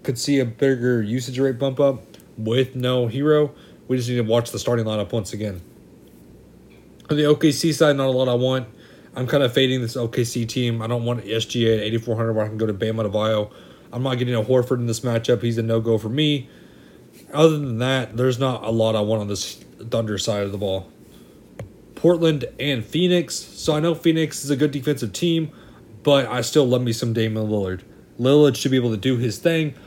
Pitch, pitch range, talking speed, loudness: 125 Hz, 110-140 Hz, 220 wpm, -21 LUFS